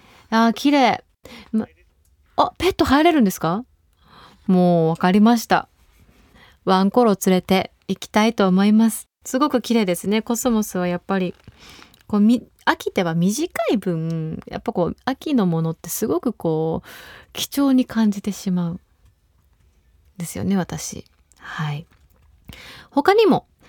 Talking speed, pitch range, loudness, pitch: 255 characters per minute, 175-235 Hz, -20 LUFS, 200 Hz